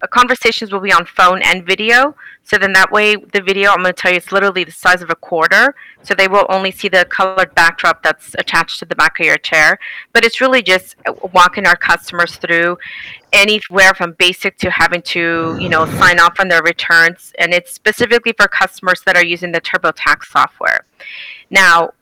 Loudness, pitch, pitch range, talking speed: -11 LUFS, 185 Hz, 175-200 Hz, 200 wpm